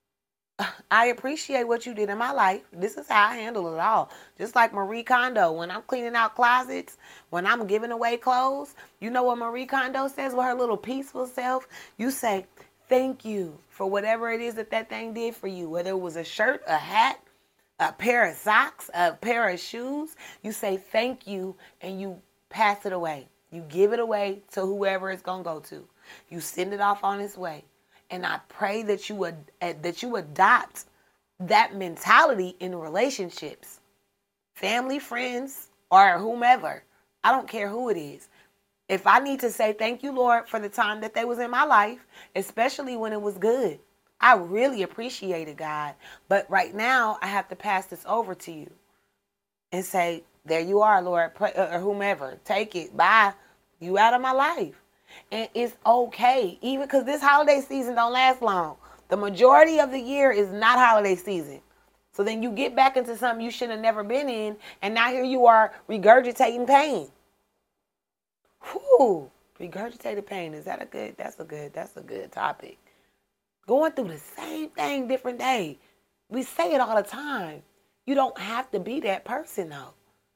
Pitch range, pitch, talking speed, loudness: 190-250 Hz, 220 Hz, 185 wpm, -24 LUFS